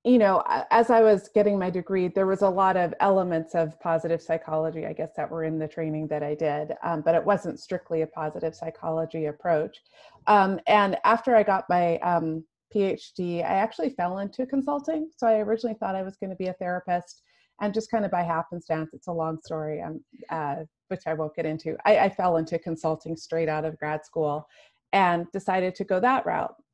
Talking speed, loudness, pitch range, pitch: 210 wpm, -26 LUFS, 160-200 Hz, 175 Hz